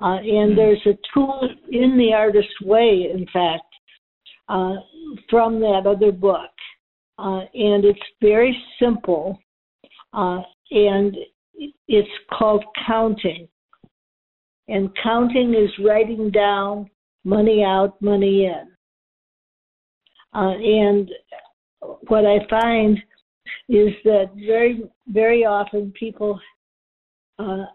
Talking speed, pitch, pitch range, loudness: 100 wpm, 210 Hz, 200-225 Hz, -18 LUFS